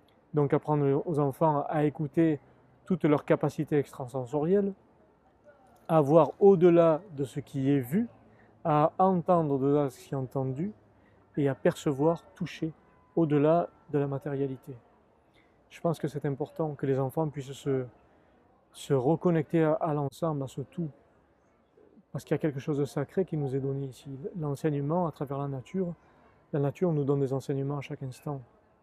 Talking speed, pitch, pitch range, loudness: 165 wpm, 145 Hz, 140-165 Hz, -29 LUFS